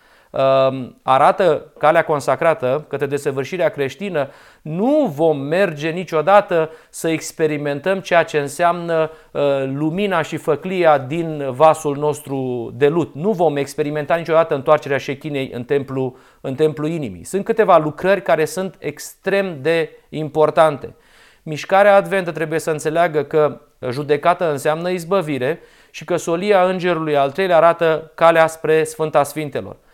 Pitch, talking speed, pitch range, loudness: 155 Hz, 125 wpm, 145-170 Hz, -18 LUFS